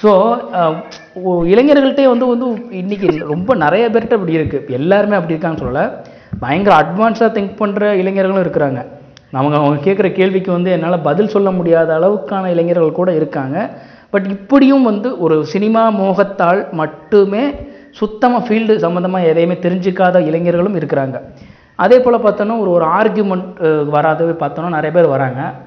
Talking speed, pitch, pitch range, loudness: 135 wpm, 185 Hz, 160-210 Hz, -13 LUFS